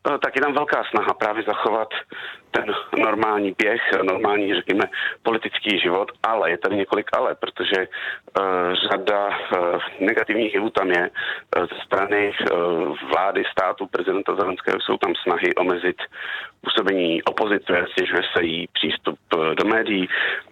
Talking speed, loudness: 125 wpm, -22 LUFS